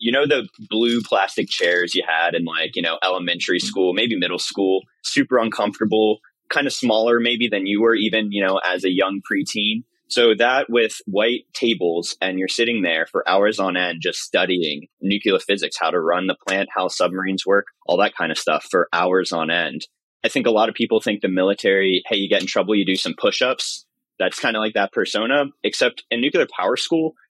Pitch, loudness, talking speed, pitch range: 100 Hz, -20 LUFS, 215 wpm, 95-110 Hz